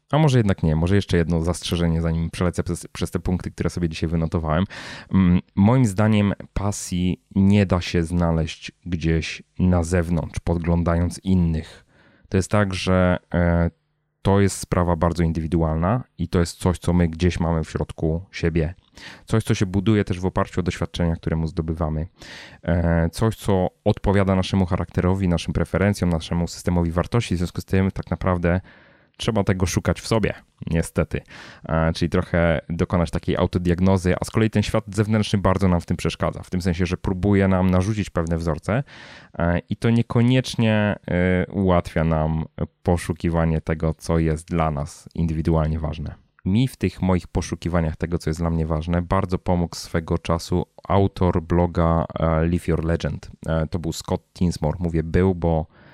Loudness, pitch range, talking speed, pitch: -22 LUFS, 85-95 Hz, 160 wpm, 90 Hz